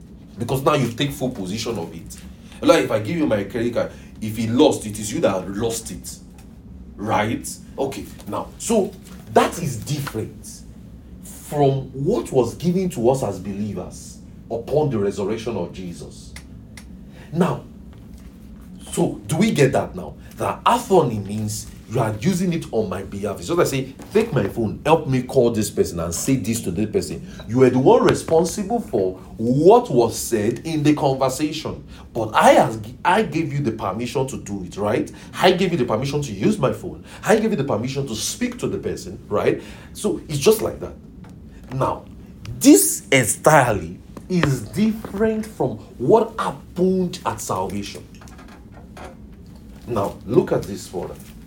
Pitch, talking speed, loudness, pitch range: 135 Hz, 170 wpm, -21 LUFS, 110-175 Hz